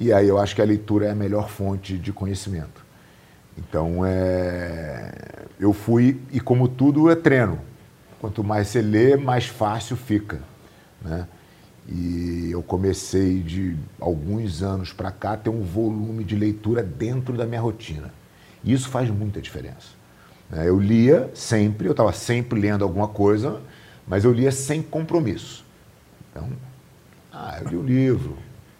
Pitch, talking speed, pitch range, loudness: 105 Hz, 155 wpm, 95-120 Hz, -22 LUFS